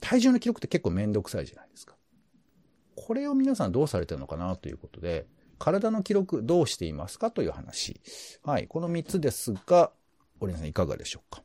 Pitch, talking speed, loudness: 160 Hz, 405 characters per minute, -29 LUFS